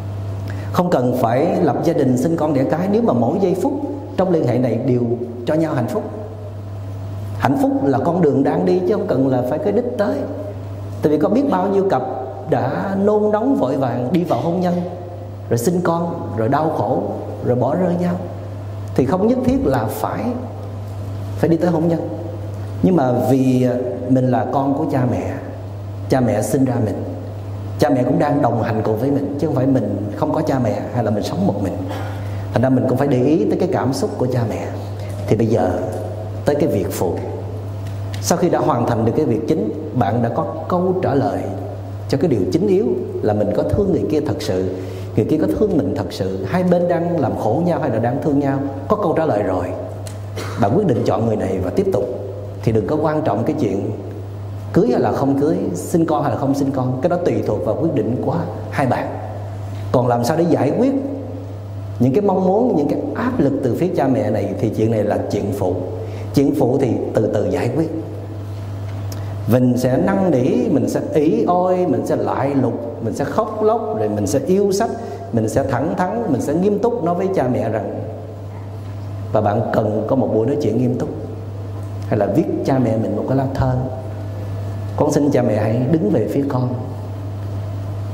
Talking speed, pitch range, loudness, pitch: 215 wpm, 100-140 Hz, -19 LUFS, 110 Hz